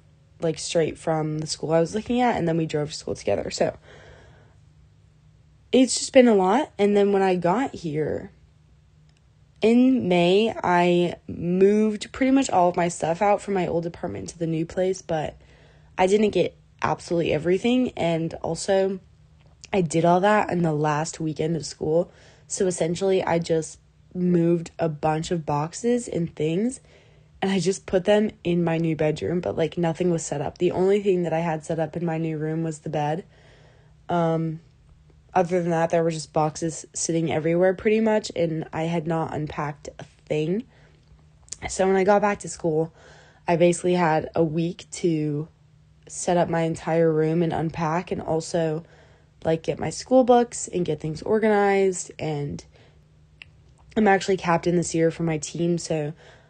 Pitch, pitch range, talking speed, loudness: 170 Hz, 155-190 Hz, 175 wpm, -23 LUFS